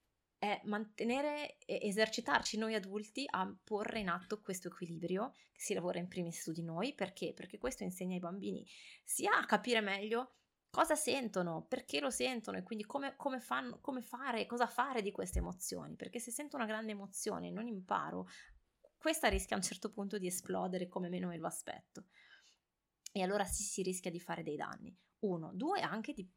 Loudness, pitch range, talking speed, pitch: -39 LUFS, 185-240 Hz, 185 wpm, 210 Hz